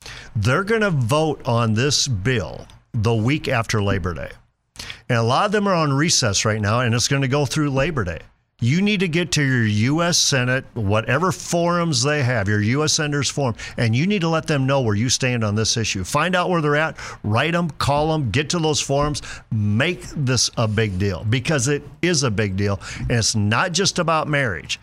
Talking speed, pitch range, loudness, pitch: 215 wpm, 115-155 Hz, -20 LUFS, 135 Hz